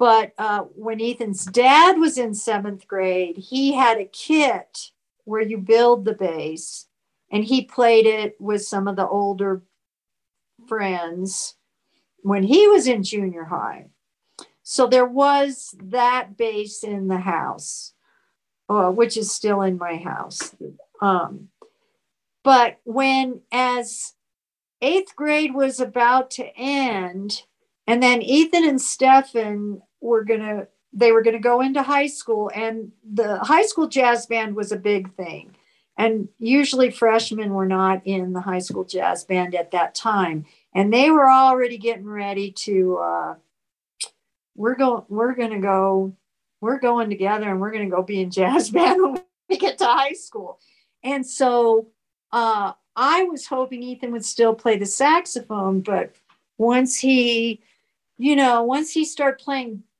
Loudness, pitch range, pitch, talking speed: -20 LUFS, 200-260 Hz, 225 Hz, 150 wpm